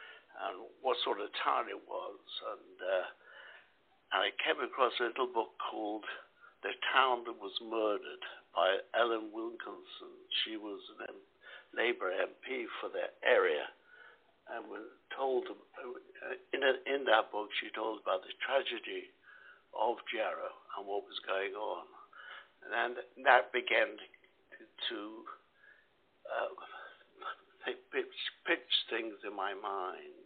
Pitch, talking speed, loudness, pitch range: 390 Hz, 130 wpm, -35 LUFS, 370-465 Hz